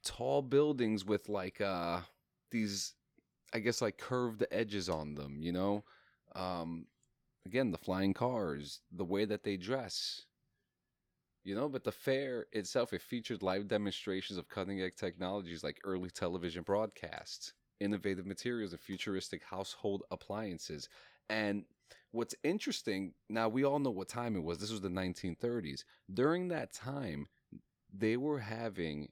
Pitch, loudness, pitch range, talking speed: 100 Hz, -38 LUFS, 90-115 Hz, 140 wpm